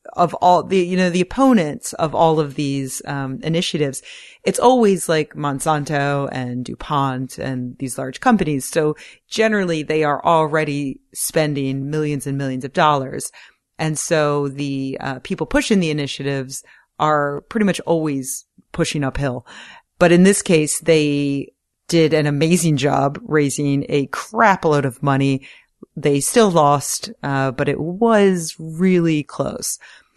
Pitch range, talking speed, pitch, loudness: 140-170 Hz, 145 wpm, 150 Hz, -18 LUFS